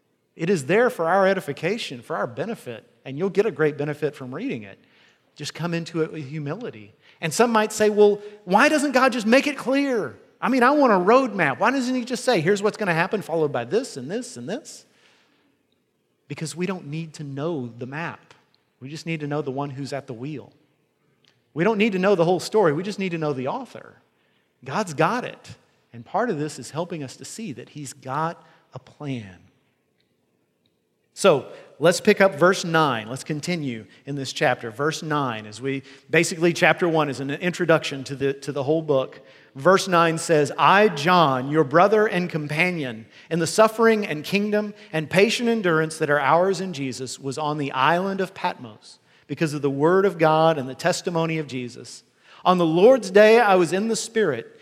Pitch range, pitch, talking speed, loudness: 140-195 Hz, 160 Hz, 205 wpm, -22 LUFS